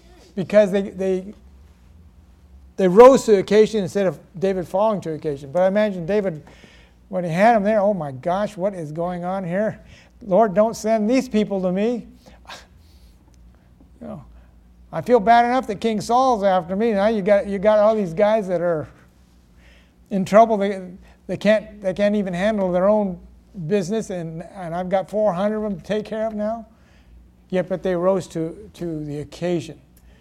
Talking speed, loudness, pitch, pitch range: 180 wpm, -20 LUFS, 190 Hz, 155-210 Hz